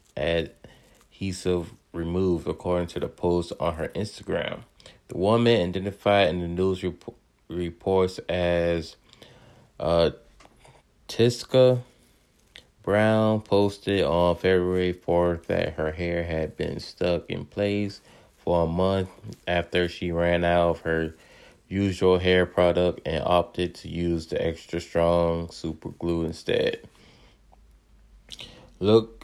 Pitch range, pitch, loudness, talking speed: 85-95 Hz, 90 Hz, -25 LUFS, 115 wpm